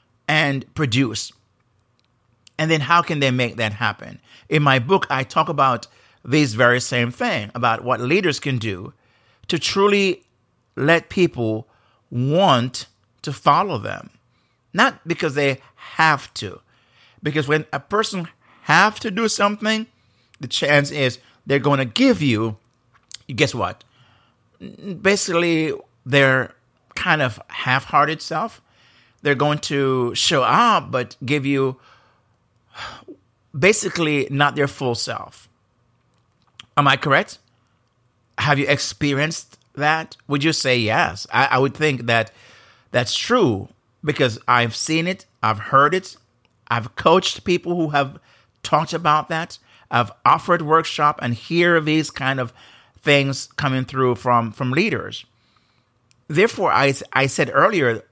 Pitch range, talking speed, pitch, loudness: 120-155 Hz, 130 wpm, 135 Hz, -19 LUFS